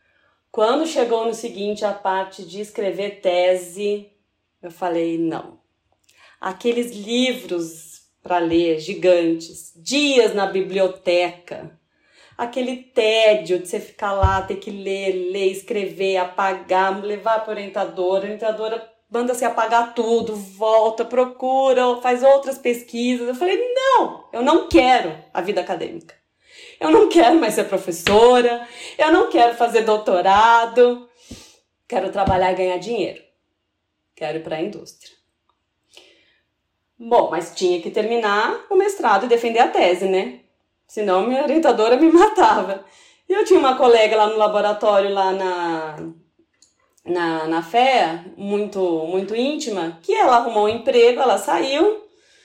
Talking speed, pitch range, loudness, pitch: 135 wpm, 190-245 Hz, -18 LUFS, 215 Hz